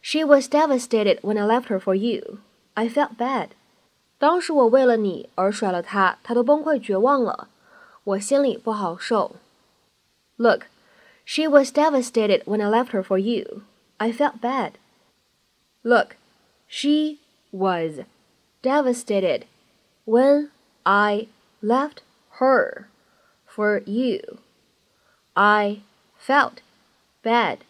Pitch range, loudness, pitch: 210-285 Hz, -21 LUFS, 235 Hz